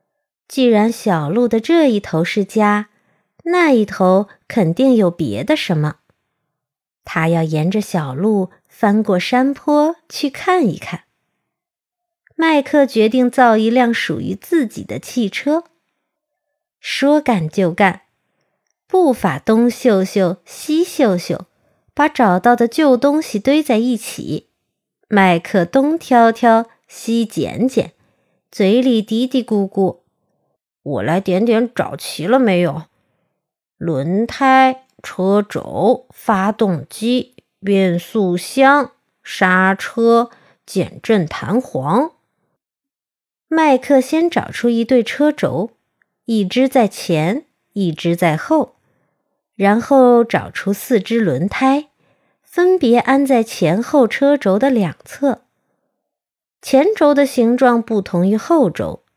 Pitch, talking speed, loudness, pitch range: 230 Hz, 160 characters per minute, -15 LUFS, 190-270 Hz